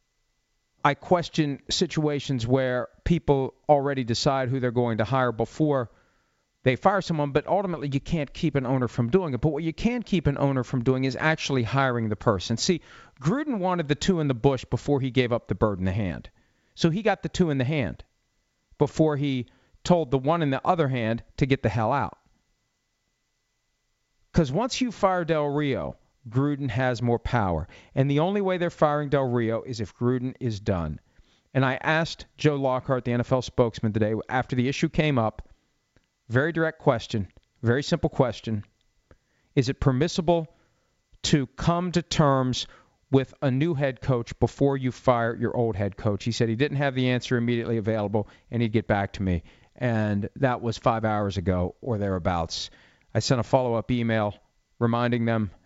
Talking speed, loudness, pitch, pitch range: 185 wpm, -26 LUFS, 130 Hz, 115-150 Hz